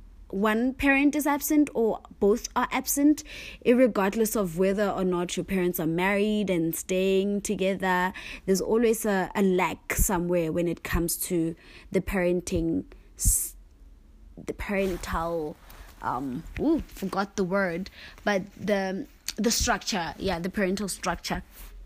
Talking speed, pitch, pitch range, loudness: 130 wpm, 195 Hz, 175-215 Hz, -27 LUFS